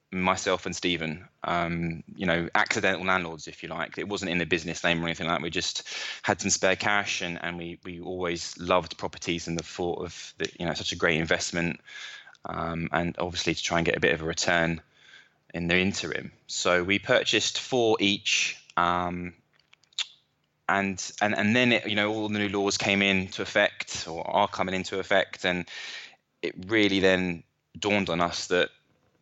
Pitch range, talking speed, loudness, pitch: 85-100 Hz, 190 wpm, -27 LUFS, 90 Hz